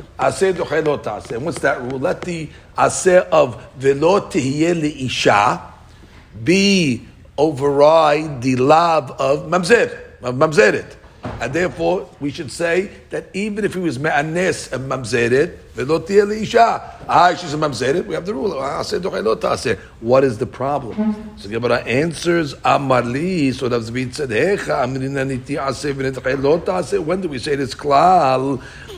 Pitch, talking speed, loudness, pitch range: 145 Hz, 145 wpm, -18 LUFS, 130-175 Hz